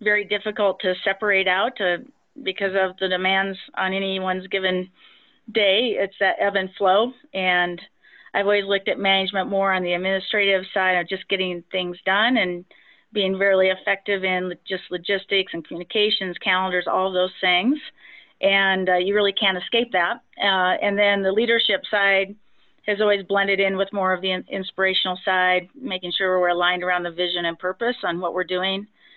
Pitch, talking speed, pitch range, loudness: 190 Hz, 175 wpm, 185-200 Hz, -21 LUFS